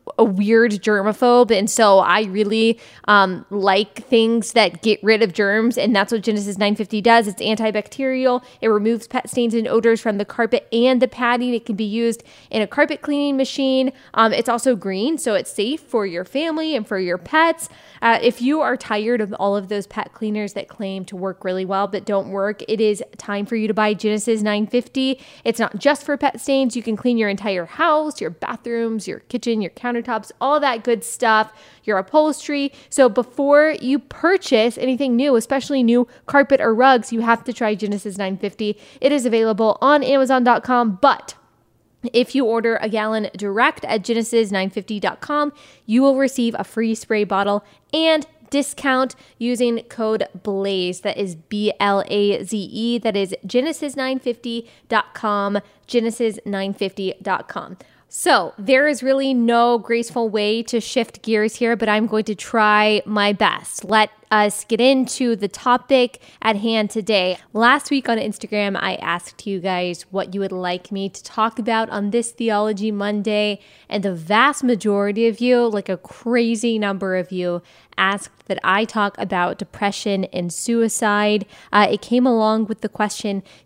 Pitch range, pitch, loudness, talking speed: 205-245 Hz, 225 Hz, -19 LUFS, 175 wpm